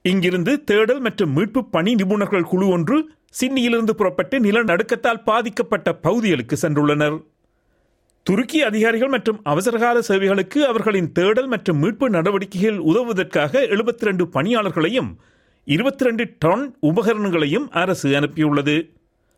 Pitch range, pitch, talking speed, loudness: 170-235 Hz, 205 Hz, 100 wpm, -19 LUFS